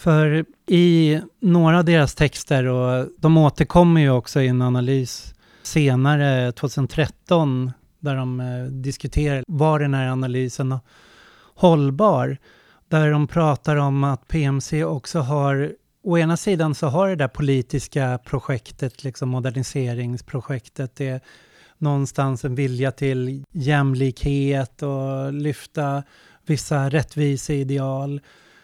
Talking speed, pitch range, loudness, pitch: 115 wpm, 130-155 Hz, -21 LUFS, 140 Hz